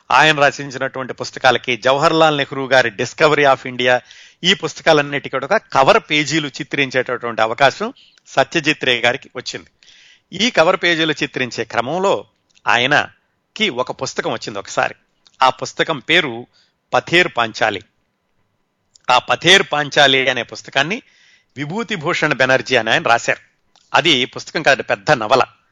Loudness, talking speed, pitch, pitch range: -16 LUFS, 115 wpm, 135 Hz, 125-160 Hz